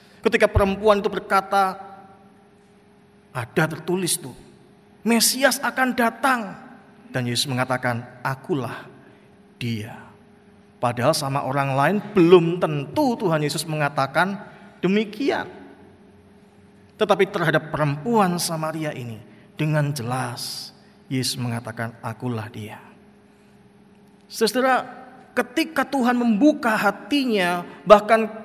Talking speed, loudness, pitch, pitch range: 90 wpm, -22 LUFS, 195 Hz, 140-215 Hz